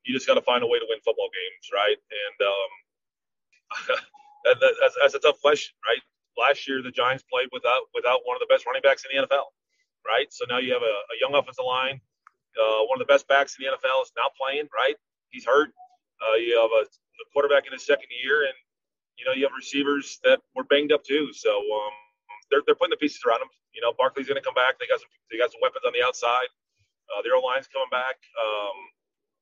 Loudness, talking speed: -24 LUFS, 235 wpm